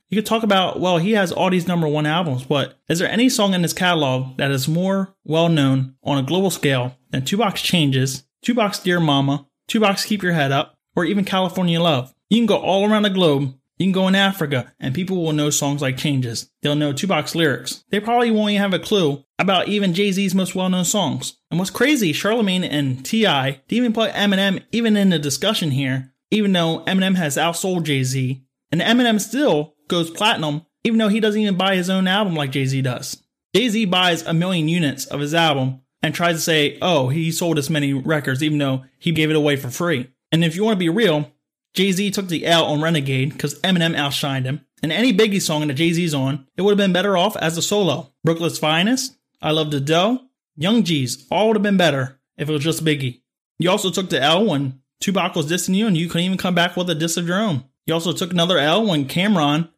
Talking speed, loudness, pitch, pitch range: 230 wpm, -19 LUFS, 165 Hz, 145-195 Hz